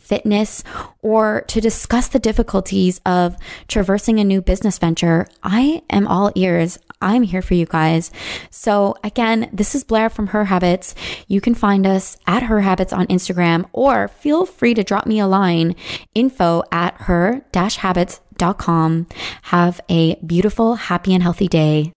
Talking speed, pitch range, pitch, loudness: 155 wpm, 175-220 Hz, 195 Hz, -17 LUFS